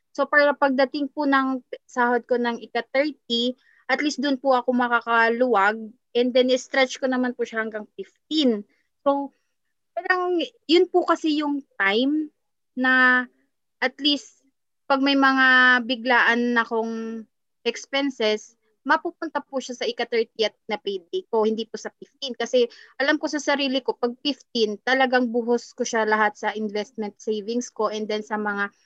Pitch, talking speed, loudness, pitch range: 250 Hz, 155 wpm, -22 LUFS, 225-280 Hz